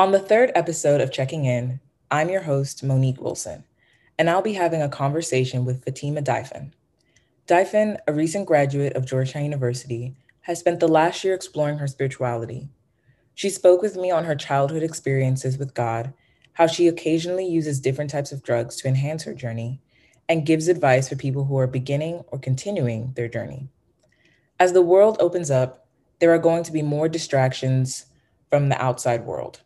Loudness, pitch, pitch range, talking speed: -22 LUFS, 140 Hz, 130-165 Hz, 175 wpm